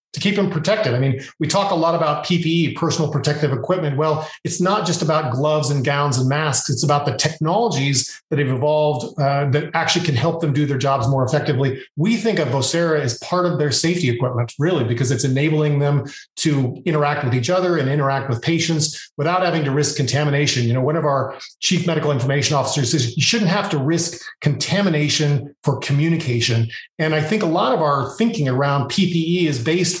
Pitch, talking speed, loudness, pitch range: 150 Hz, 205 wpm, -19 LUFS, 140-165 Hz